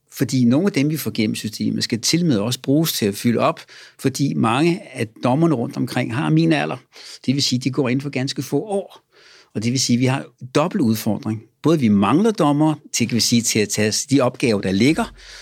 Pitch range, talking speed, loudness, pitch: 115-150 Hz, 235 wpm, -19 LUFS, 130 Hz